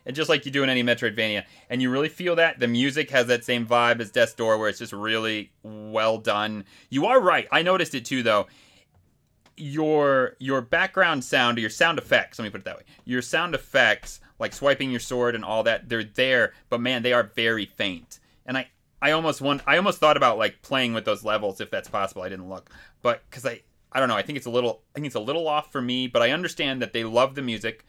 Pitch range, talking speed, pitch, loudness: 110-140 Hz, 245 wpm, 125 Hz, -23 LUFS